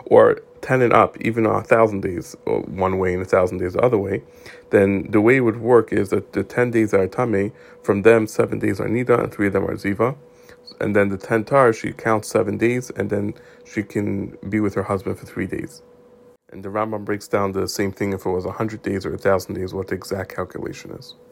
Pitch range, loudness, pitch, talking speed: 100-115 Hz, -20 LUFS, 105 Hz, 240 wpm